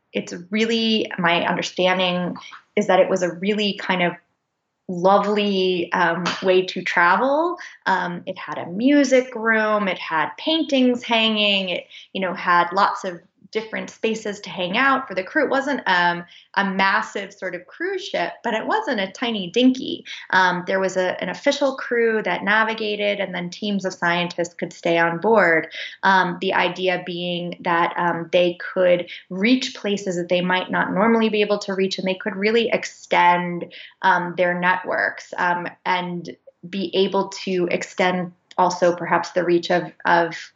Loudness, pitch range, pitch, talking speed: -21 LUFS, 175-215 Hz, 185 Hz, 165 wpm